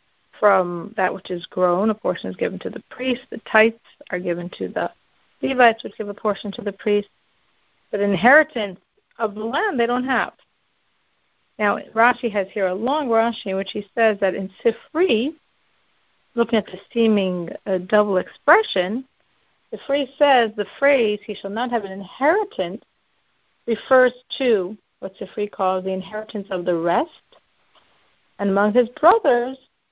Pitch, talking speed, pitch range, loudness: 215 Hz, 160 wpm, 195-245 Hz, -21 LUFS